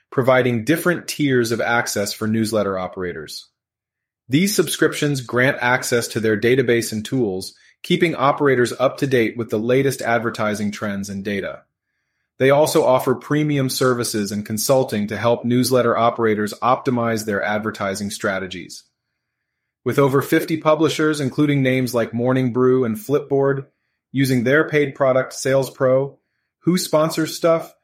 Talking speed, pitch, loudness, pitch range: 135 wpm, 125 Hz, -19 LUFS, 110-140 Hz